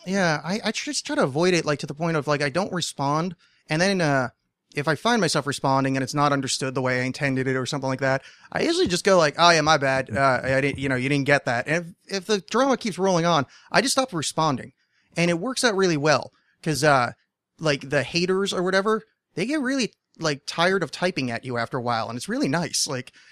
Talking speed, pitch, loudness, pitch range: 250 wpm, 155 Hz, -23 LUFS, 135-190 Hz